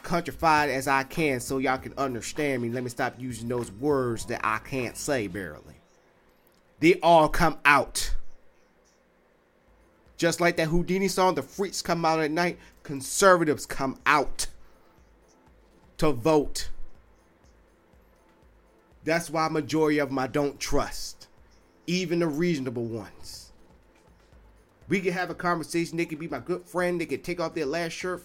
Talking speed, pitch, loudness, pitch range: 150 wpm, 145 Hz, -26 LUFS, 115-170 Hz